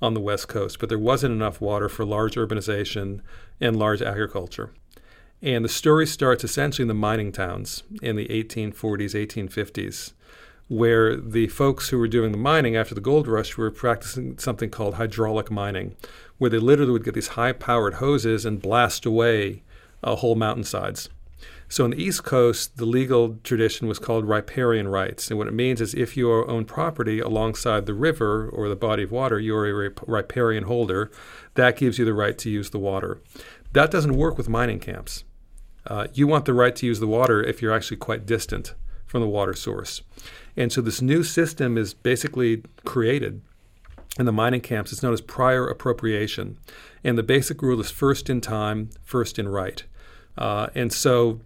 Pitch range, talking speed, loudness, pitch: 105-125 Hz, 185 wpm, -23 LUFS, 115 Hz